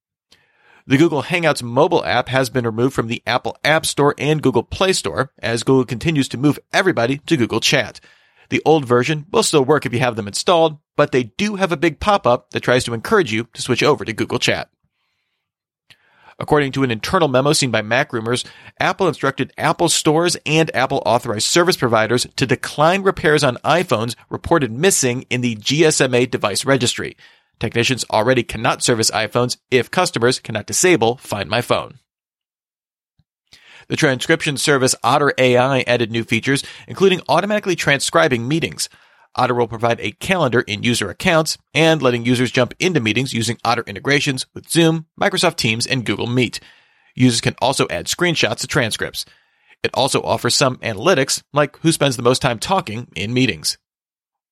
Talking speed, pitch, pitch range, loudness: 170 wpm, 130 Hz, 120-155 Hz, -17 LUFS